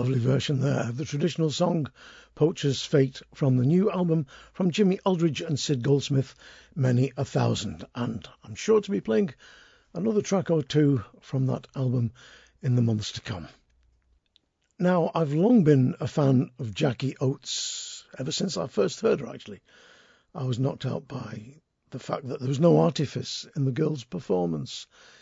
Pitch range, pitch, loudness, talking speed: 125-170 Hz, 140 Hz, -26 LUFS, 170 wpm